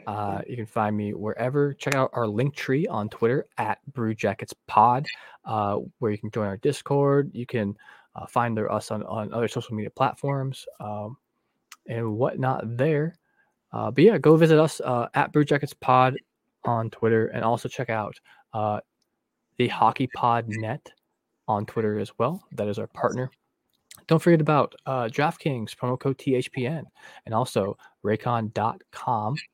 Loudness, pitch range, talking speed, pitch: -25 LUFS, 110-140 Hz, 160 wpm, 120 Hz